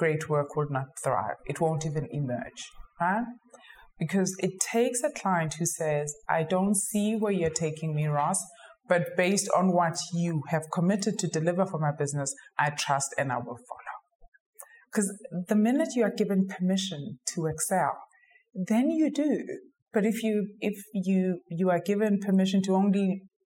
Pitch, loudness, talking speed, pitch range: 185 Hz, -28 LUFS, 170 wpm, 160-210 Hz